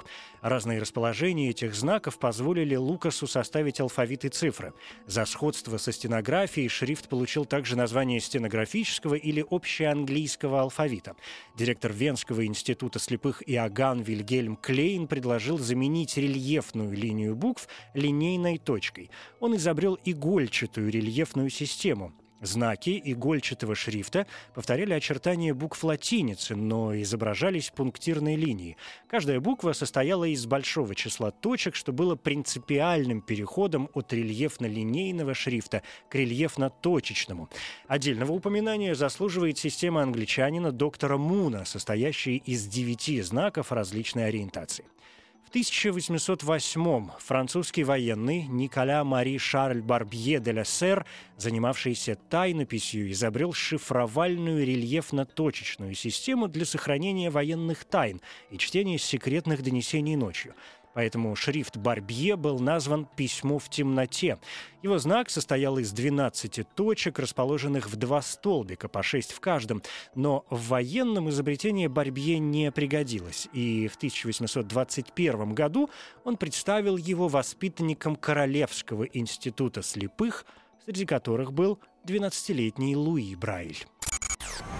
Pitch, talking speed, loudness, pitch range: 140 Hz, 105 wpm, -29 LUFS, 120-160 Hz